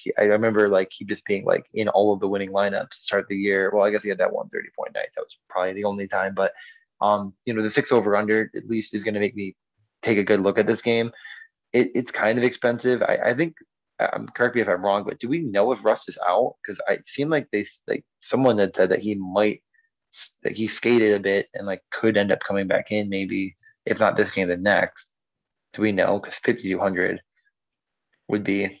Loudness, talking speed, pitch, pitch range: -23 LUFS, 240 wpm, 105 Hz, 100-115 Hz